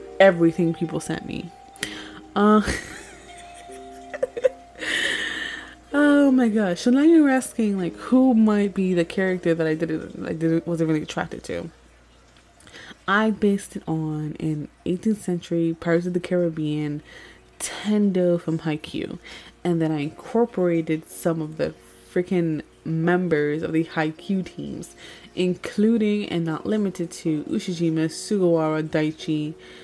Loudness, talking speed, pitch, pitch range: -23 LUFS, 125 wpm, 175 Hz, 160-215 Hz